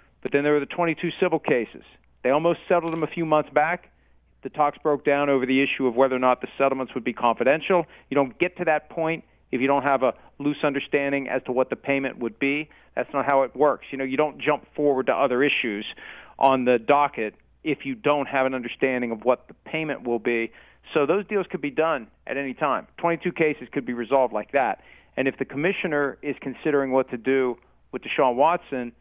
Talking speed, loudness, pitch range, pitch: 225 wpm, -24 LUFS, 130-150 Hz, 140 Hz